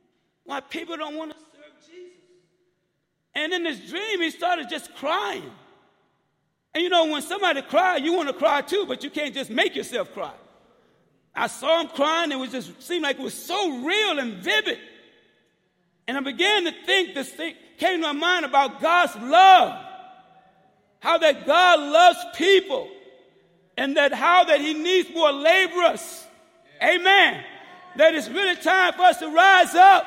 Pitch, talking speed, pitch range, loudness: 330 Hz, 170 wpm, 285-360 Hz, -20 LUFS